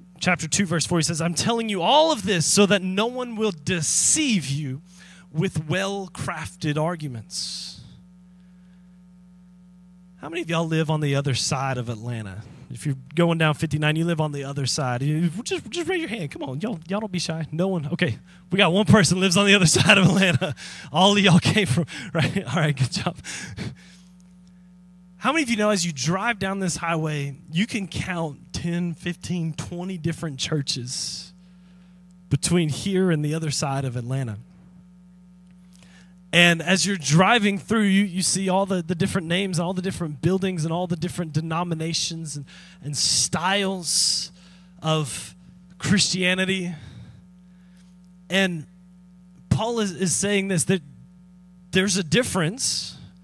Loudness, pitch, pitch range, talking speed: -22 LUFS, 180 Hz, 160-185 Hz, 160 wpm